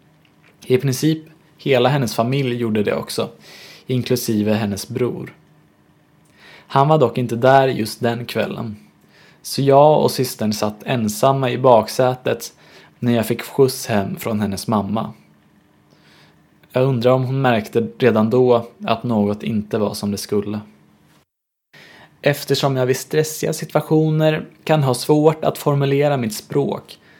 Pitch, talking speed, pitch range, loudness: 125 Hz, 135 wpm, 110-140 Hz, -18 LUFS